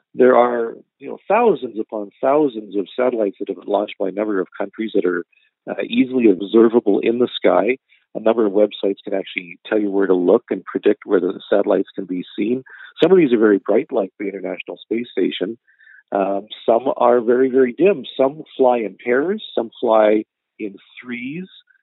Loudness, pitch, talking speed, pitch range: -18 LUFS, 115 Hz, 190 wpm, 100-125 Hz